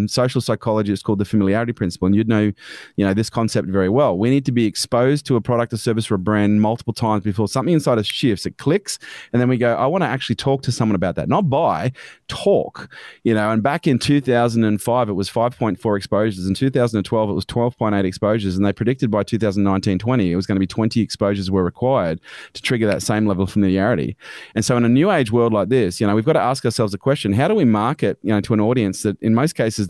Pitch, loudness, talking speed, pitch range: 110 Hz, -19 LUFS, 245 wpm, 100-120 Hz